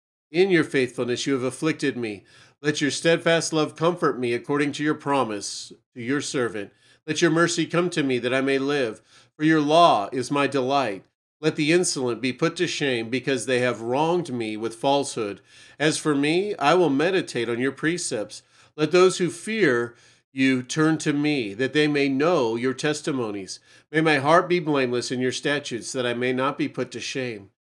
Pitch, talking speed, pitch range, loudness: 140 Hz, 195 wpm, 125-155 Hz, -23 LUFS